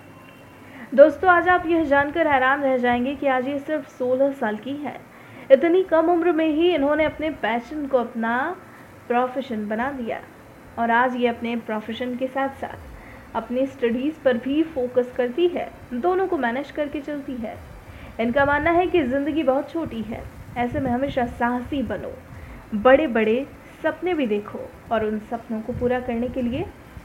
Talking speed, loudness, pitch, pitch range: 170 wpm, -22 LUFS, 265 Hz, 240-300 Hz